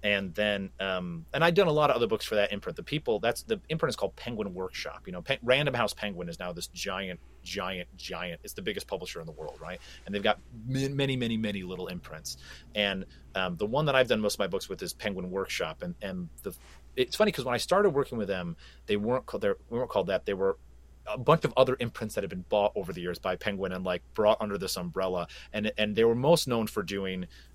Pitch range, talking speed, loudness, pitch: 90-135 Hz, 255 wpm, -30 LUFS, 105 Hz